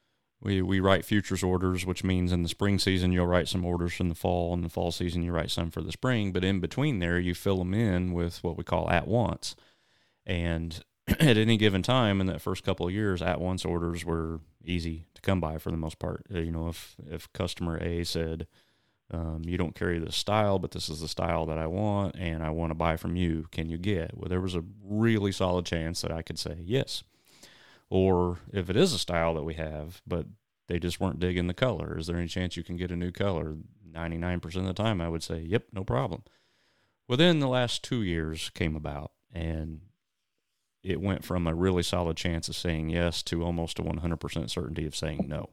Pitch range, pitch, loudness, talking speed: 85-95 Hz, 85 Hz, -30 LUFS, 225 wpm